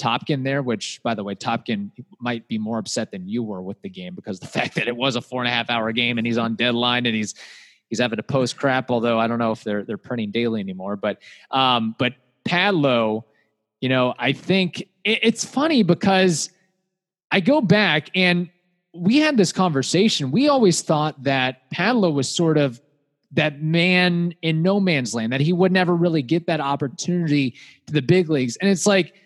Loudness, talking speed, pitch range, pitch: -21 LUFS, 205 wpm, 120-185 Hz, 145 Hz